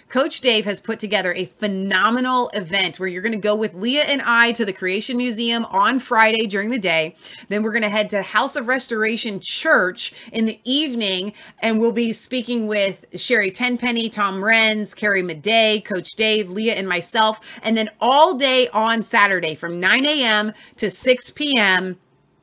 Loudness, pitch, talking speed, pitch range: -19 LUFS, 220 Hz, 180 wpm, 200-240 Hz